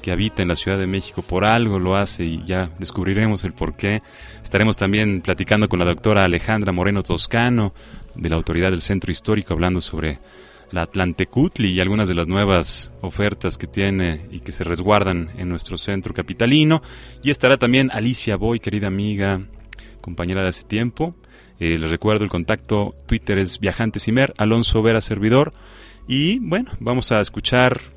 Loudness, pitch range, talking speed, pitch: -20 LUFS, 90-110 Hz, 170 wpm, 100 Hz